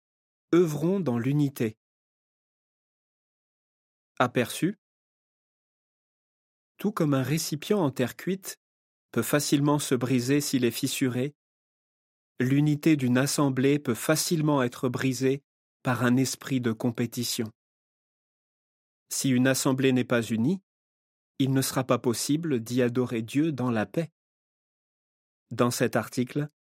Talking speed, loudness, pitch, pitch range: 110 wpm, -27 LUFS, 130 Hz, 125-145 Hz